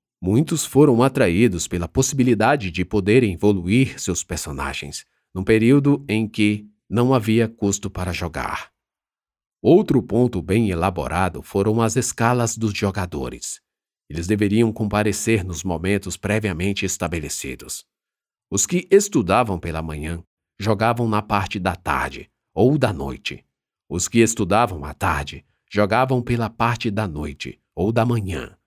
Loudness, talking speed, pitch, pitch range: -20 LUFS, 130 wpm, 105 Hz, 90-115 Hz